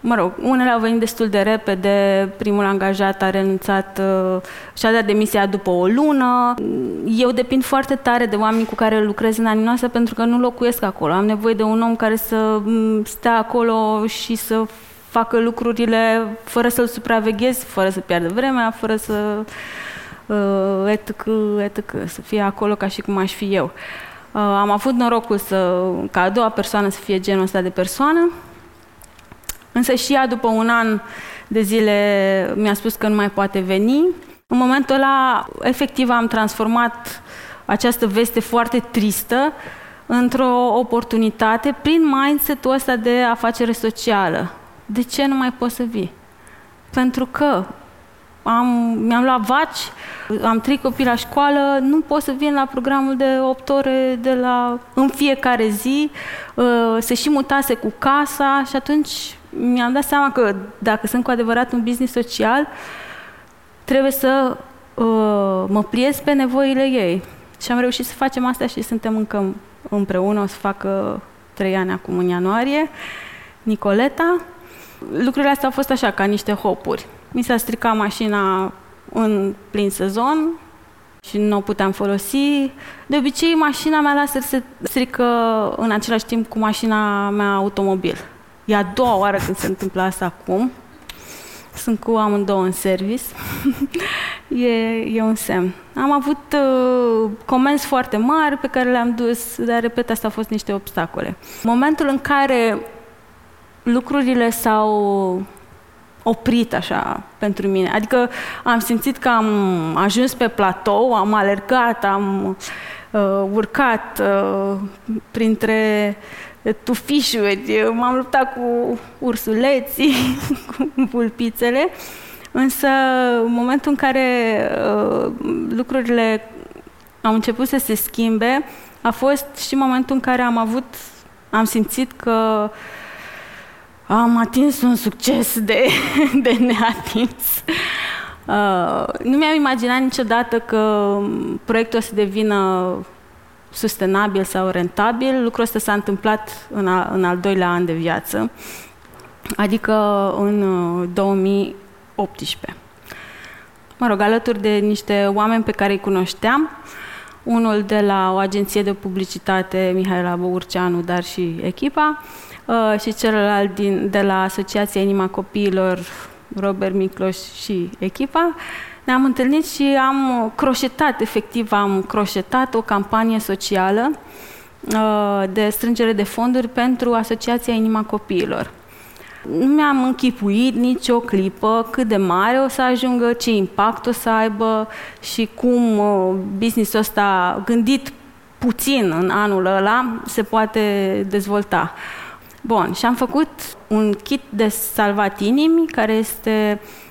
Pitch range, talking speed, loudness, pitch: 205-255 Hz, 135 wpm, -18 LUFS, 225 Hz